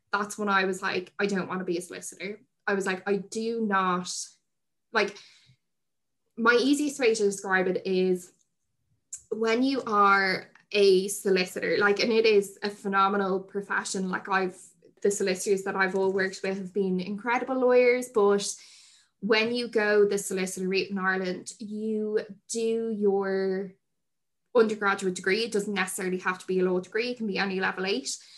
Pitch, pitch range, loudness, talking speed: 200 Hz, 190-215 Hz, -27 LUFS, 165 wpm